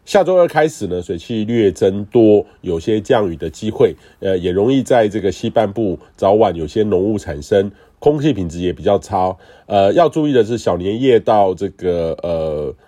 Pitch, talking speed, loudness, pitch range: 105 Hz, 265 characters per minute, -16 LUFS, 90-120 Hz